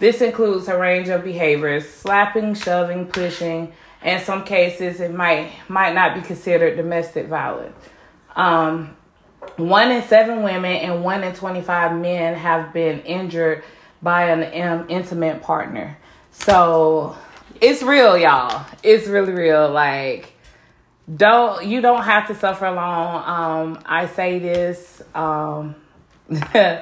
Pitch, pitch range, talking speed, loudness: 175 Hz, 165-190 Hz, 130 wpm, -18 LUFS